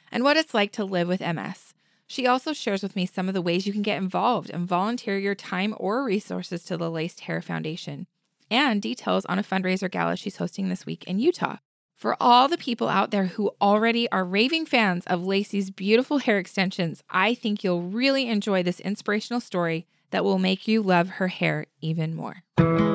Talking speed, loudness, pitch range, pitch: 200 wpm, -25 LUFS, 180-220 Hz, 195 Hz